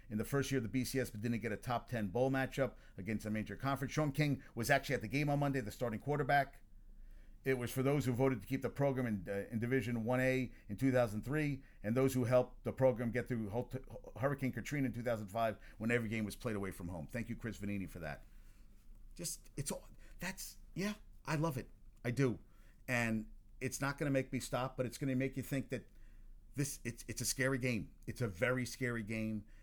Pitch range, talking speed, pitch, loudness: 110-135 Hz, 225 wpm, 120 Hz, -38 LUFS